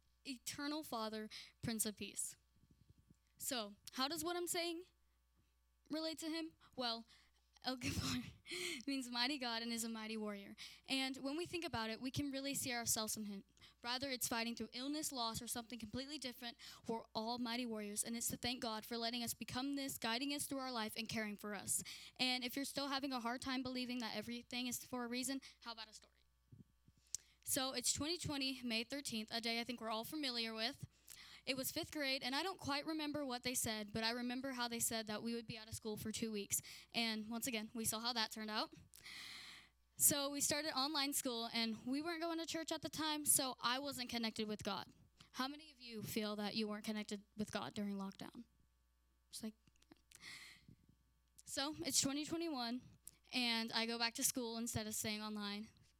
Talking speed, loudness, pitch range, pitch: 200 wpm, -42 LUFS, 220-275 Hz, 240 Hz